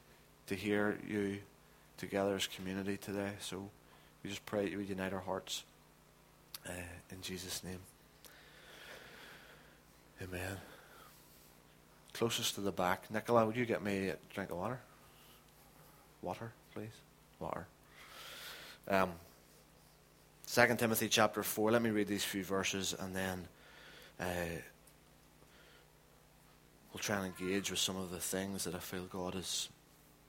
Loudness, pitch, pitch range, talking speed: -38 LUFS, 95 Hz, 90-105 Hz, 130 wpm